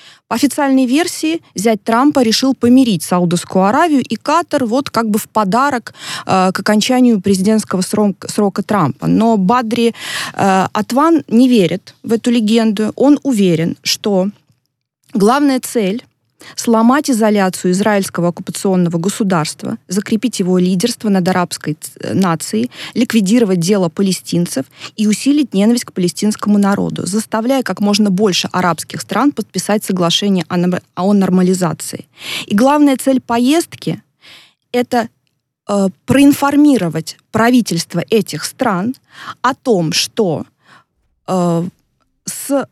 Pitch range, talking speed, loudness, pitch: 185-245 Hz, 115 wpm, -14 LUFS, 210 Hz